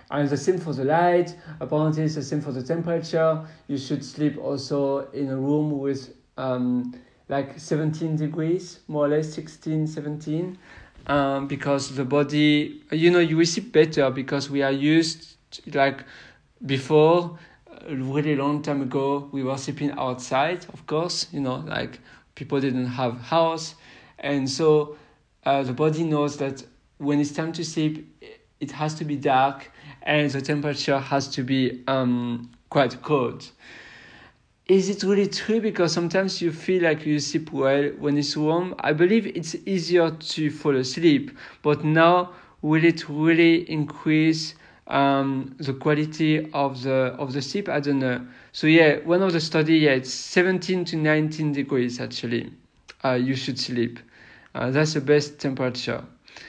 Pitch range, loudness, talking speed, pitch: 135-160 Hz, -23 LUFS, 160 wpm, 150 Hz